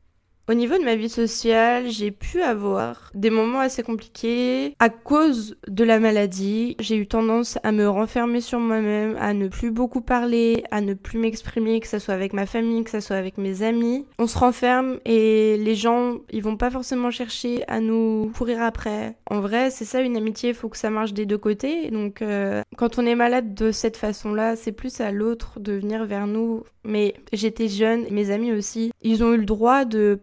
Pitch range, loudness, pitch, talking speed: 215-240 Hz, -22 LUFS, 225 Hz, 210 wpm